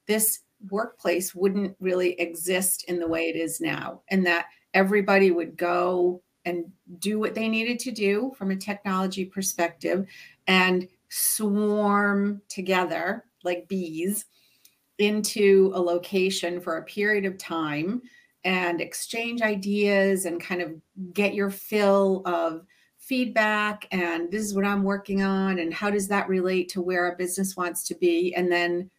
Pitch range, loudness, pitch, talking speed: 175-205 Hz, -25 LUFS, 190 Hz, 150 wpm